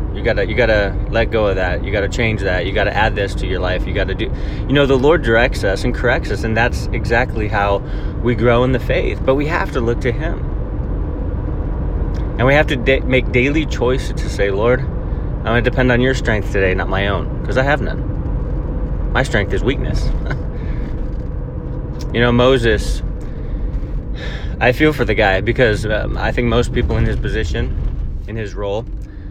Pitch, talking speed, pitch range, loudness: 105 Hz, 210 wpm, 95-120 Hz, -17 LUFS